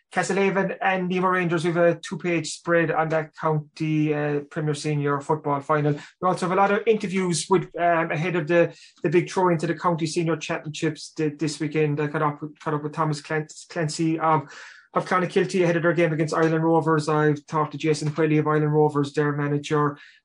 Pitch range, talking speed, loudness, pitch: 150-175 Hz, 200 wpm, -23 LUFS, 160 Hz